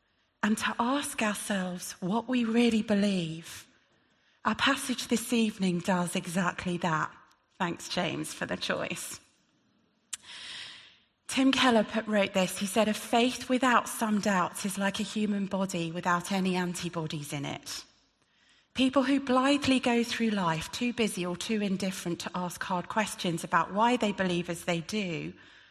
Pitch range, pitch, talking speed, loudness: 180-235 Hz, 205 Hz, 150 wpm, -29 LUFS